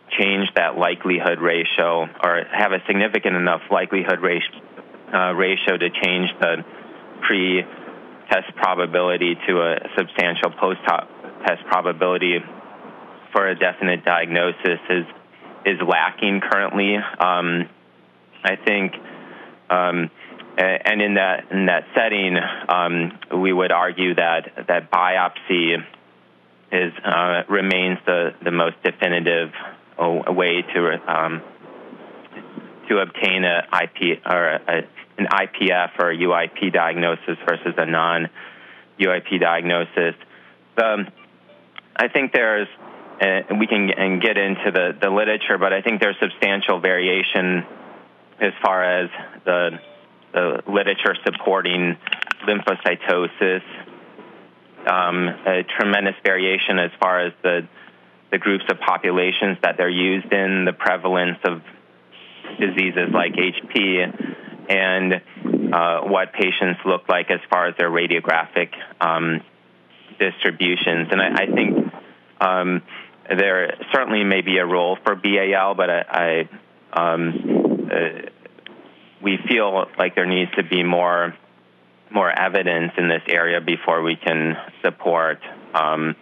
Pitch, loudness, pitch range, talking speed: 90 Hz, -20 LUFS, 85-95 Hz, 120 wpm